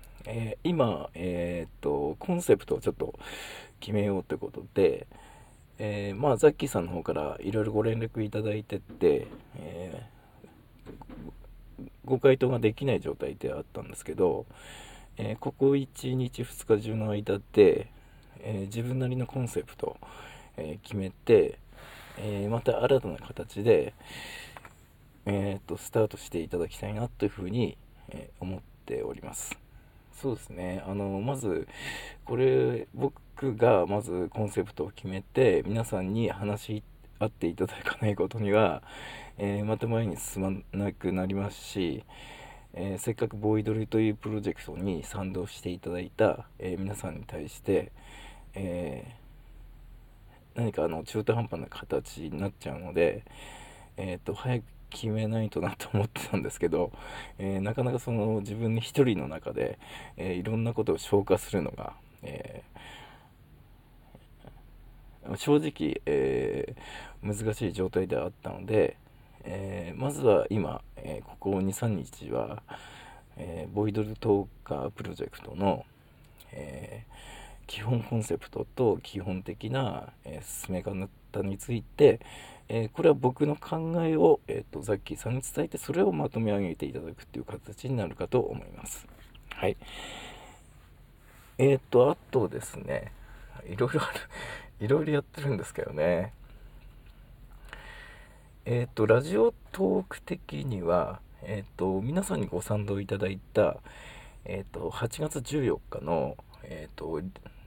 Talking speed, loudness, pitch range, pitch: 275 characters per minute, -30 LUFS, 95-125 Hz, 110 Hz